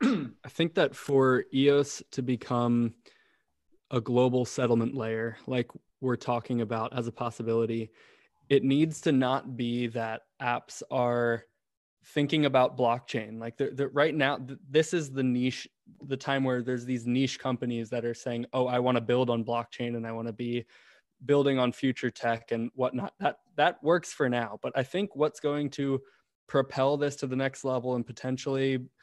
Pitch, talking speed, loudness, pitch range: 125 Hz, 175 wpm, -29 LUFS, 120-135 Hz